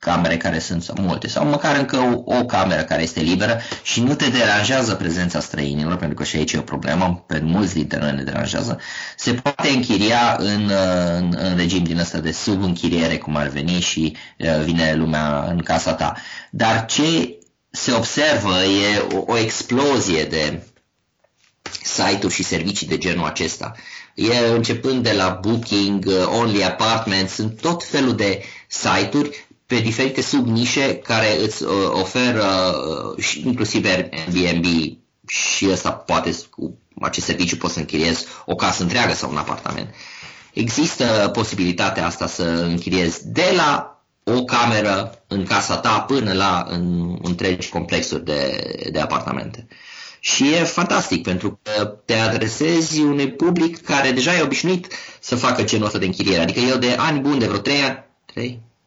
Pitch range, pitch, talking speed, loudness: 85-120 Hz, 100 Hz, 155 wpm, -19 LUFS